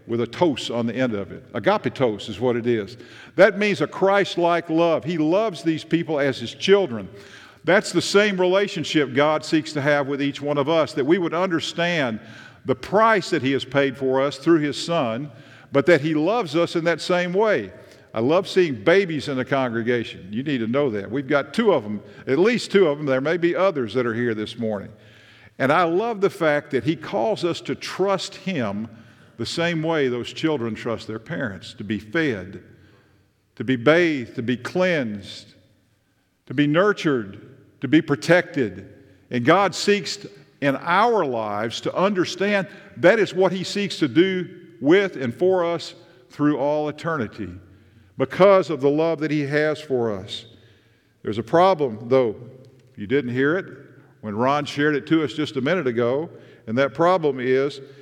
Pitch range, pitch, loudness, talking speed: 120-170 Hz, 145 Hz, -21 LUFS, 190 wpm